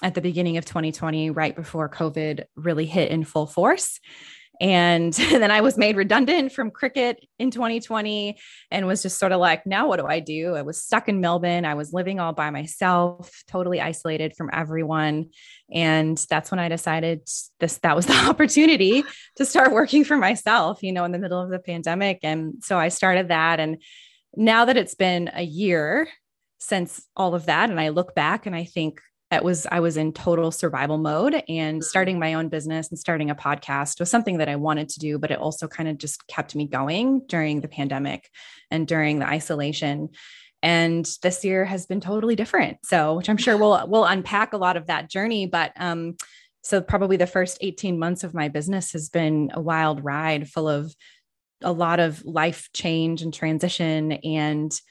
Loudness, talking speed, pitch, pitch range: -22 LUFS, 195 wpm, 170 Hz, 155-190 Hz